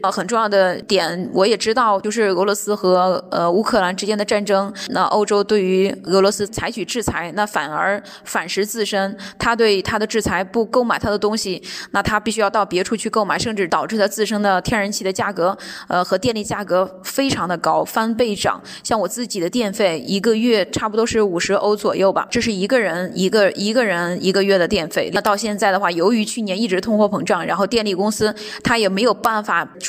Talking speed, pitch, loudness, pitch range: 320 characters per minute, 205 Hz, -18 LUFS, 190-220 Hz